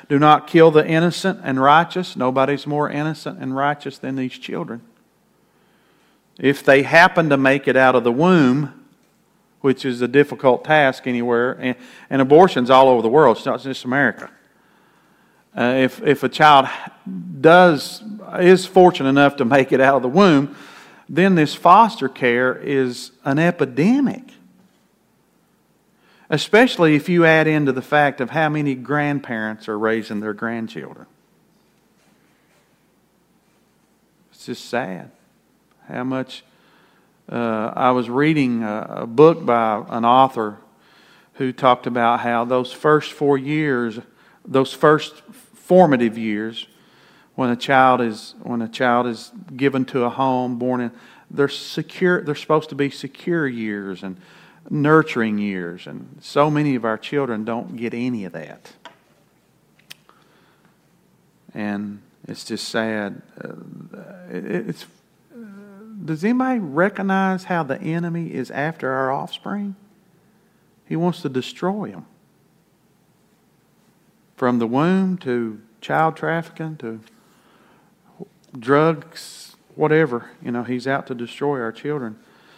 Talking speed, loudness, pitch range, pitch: 130 wpm, -18 LUFS, 125-165 Hz, 140 Hz